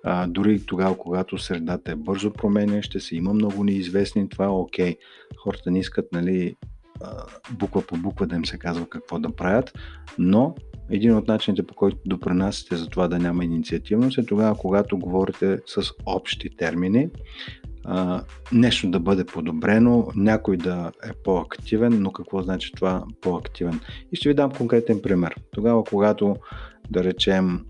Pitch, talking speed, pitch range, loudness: 95 Hz, 160 wpm, 90-105 Hz, -23 LUFS